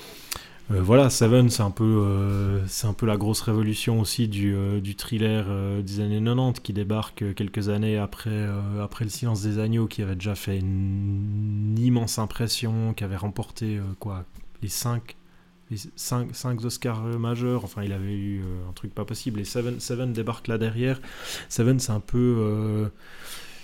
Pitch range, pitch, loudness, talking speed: 100-115 Hz, 110 Hz, -26 LUFS, 175 wpm